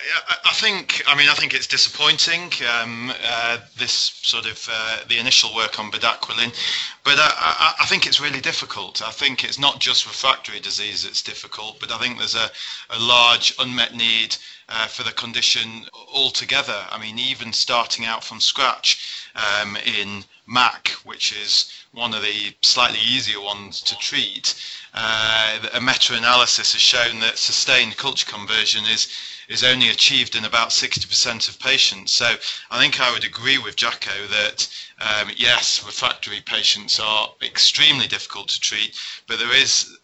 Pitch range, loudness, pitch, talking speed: 110-130 Hz, -18 LUFS, 115 Hz, 160 wpm